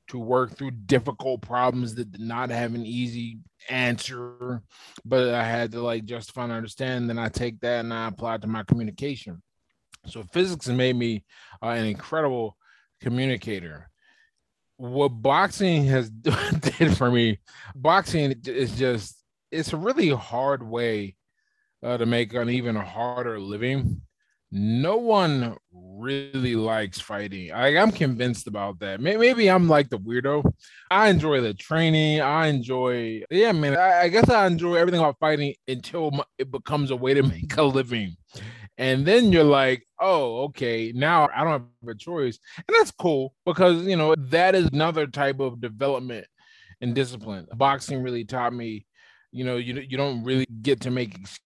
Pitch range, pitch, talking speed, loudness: 115-140 Hz, 125 Hz, 160 wpm, -24 LUFS